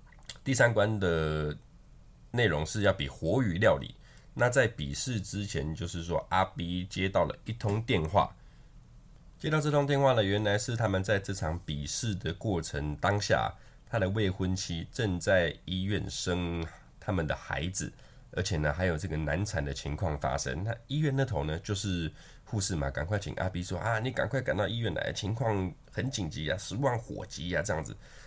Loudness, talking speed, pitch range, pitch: -31 LUFS, 260 characters per minute, 80-110 Hz, 95 Hz